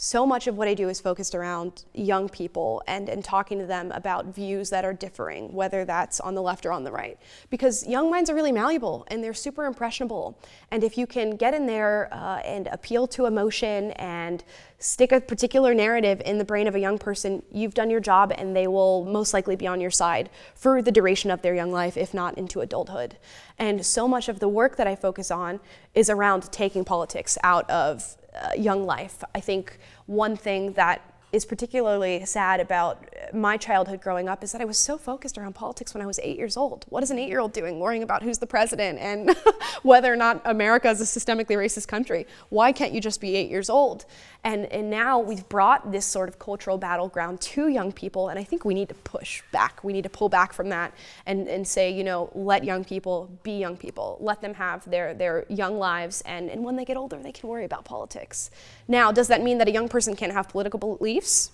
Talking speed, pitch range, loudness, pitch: 225 wpm, 190-235 Hz, -25 LUFS, 205 Hz